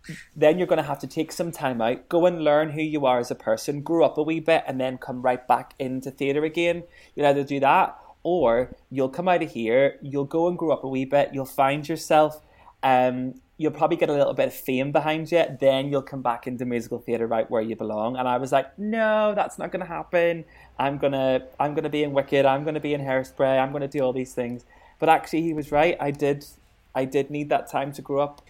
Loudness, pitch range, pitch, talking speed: -24 LUFS, 130-160 Hz, 140 Hz, 250 wpm